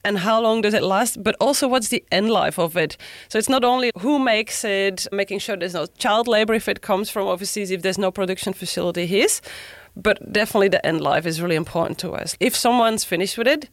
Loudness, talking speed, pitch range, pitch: -20 LUFS, 230 wpm, 190-230 Hz, 205 Hz